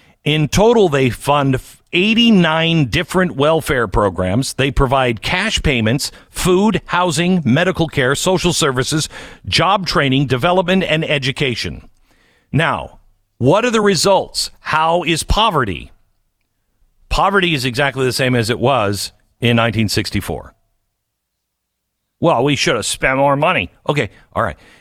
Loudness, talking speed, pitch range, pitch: -15 LUFS, 125 wpm, 115-170 Hz, 140 Hz